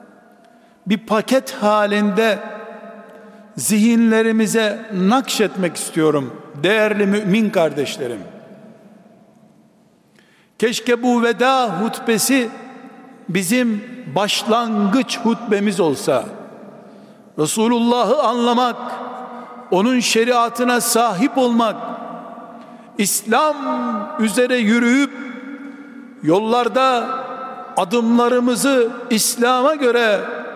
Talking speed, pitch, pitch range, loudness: 60 wpm, 230 Hz, 215-245 Hz, -17 LUFS